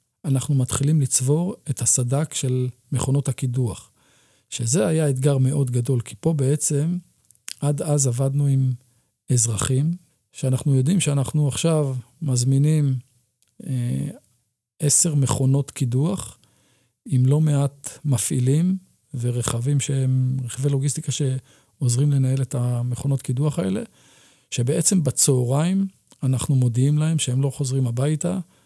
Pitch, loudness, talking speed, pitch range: 135 Hz, -22 LUFS, 110 wpm, 125-150 Hz